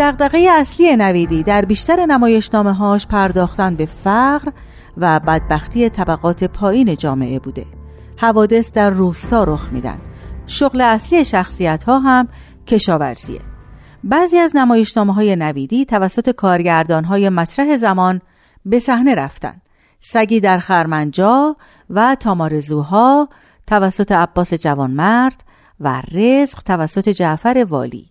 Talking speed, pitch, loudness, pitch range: 110 wpm, 205 Hz, -14 LUFS, 170-245 Hz